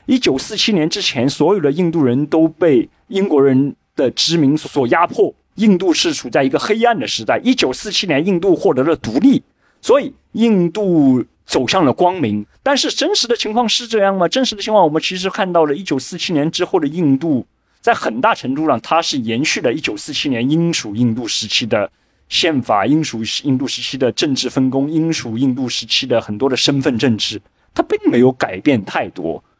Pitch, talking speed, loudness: 170 Hz, 300 characters per minute, -16 LUFS